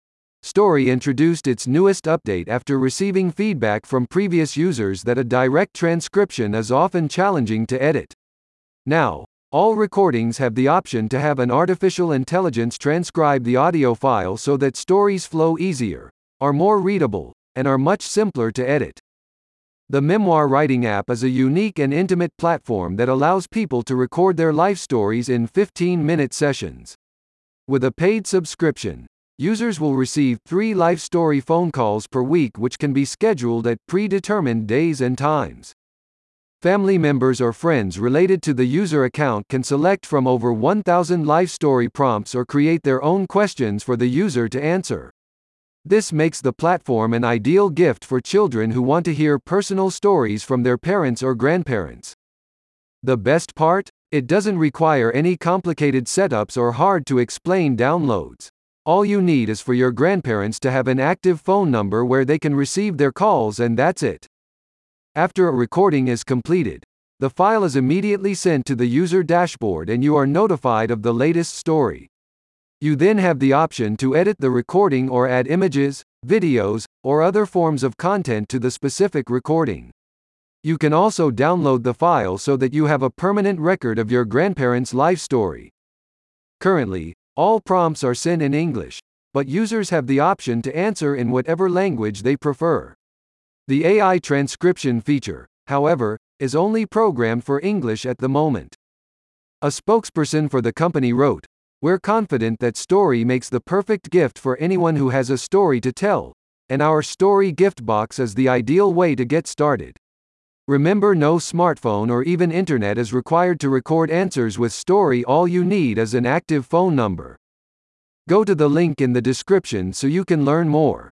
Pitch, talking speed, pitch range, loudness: 145 Hz, 165 wpm, 125-180 Hz, -19 LUFS